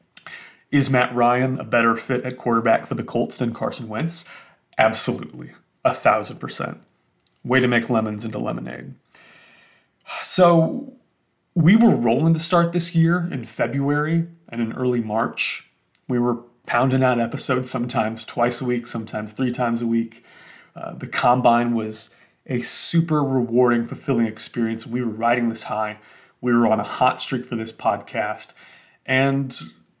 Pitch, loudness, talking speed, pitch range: 120 Hz, -20 LUFS, 150 wpm, 115-135 Hz